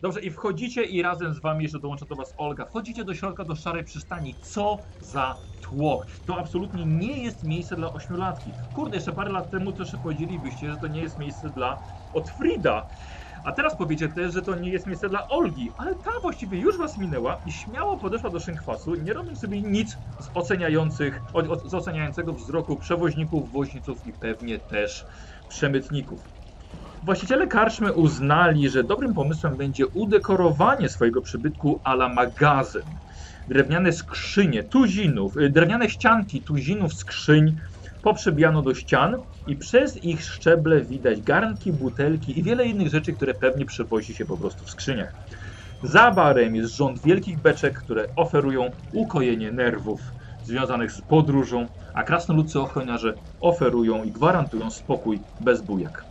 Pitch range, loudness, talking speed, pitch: 130-180 Hz, -24 LUFS, 155 wpm, 155 Hz